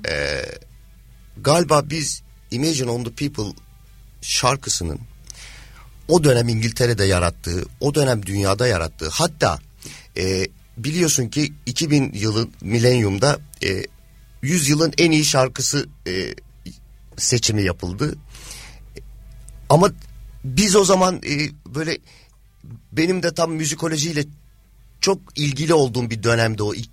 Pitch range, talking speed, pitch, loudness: 110-150 Hz, 105 wpm, 125 Hz, -20 LUFS